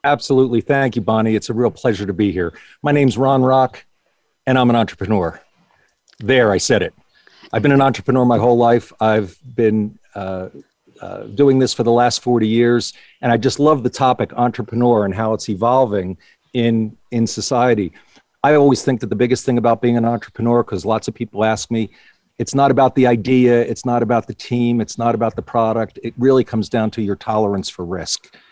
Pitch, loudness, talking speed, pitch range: 120 Hz, -17 LUFS, 200 wpm, 110-125 Hz